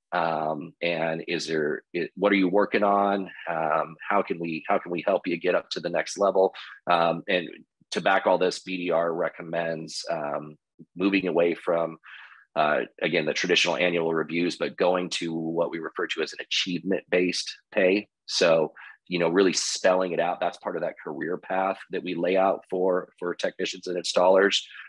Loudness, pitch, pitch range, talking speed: -26 LUFS, 85 Hz, 85-95 Hz, 185 wpm